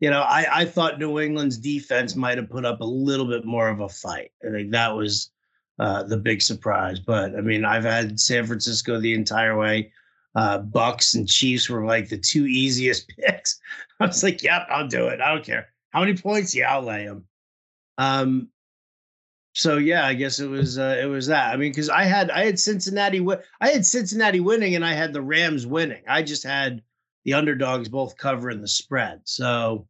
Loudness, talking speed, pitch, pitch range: -22 LUFS, 210 wpm, 130 Hz, 110-155 Hz